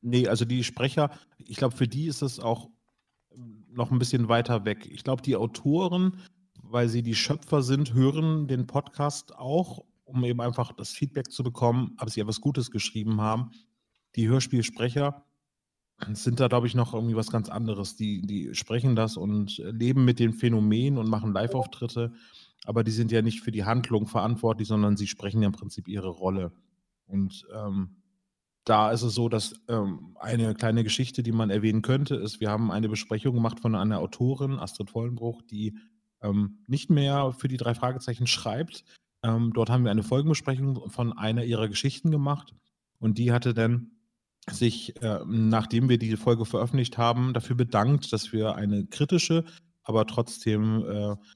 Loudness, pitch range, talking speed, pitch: -27 LUFS, 110-130 Hz, 175 wpm, 120 Hz